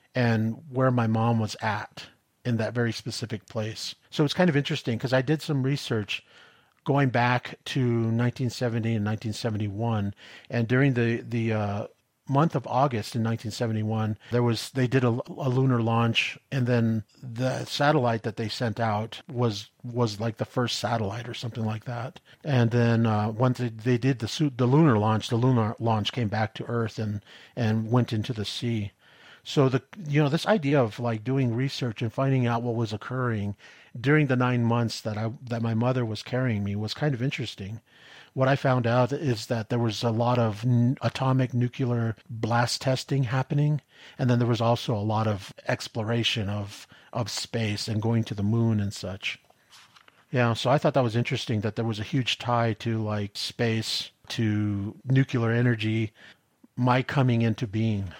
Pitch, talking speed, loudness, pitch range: 120 Hz, 185 wpm, -26 LUFS, 110-130 Hz